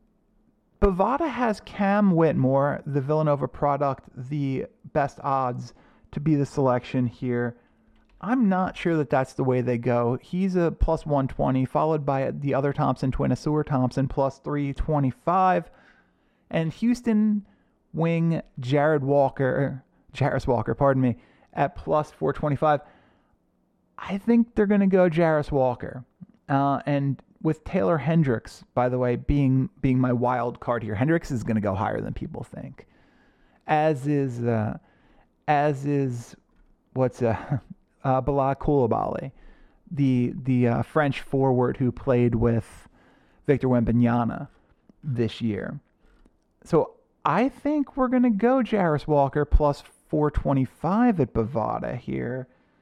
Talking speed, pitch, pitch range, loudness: 135 wpm, 140 Hz, 125-160 Hz, -24 LUFS